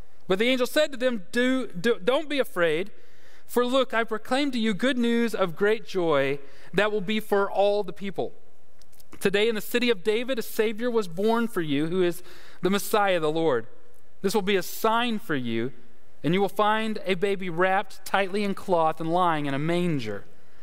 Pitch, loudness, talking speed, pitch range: 205 Hz, -26 LUFS, 200 wpm, 180-230 Hz